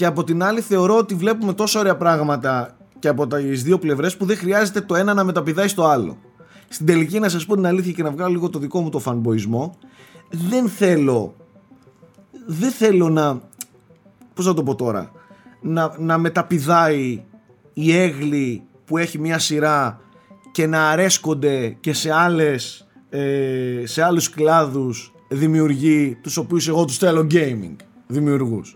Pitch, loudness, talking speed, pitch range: 165 Hz, -19 LUFS, 160 wpm, 145-185 Hz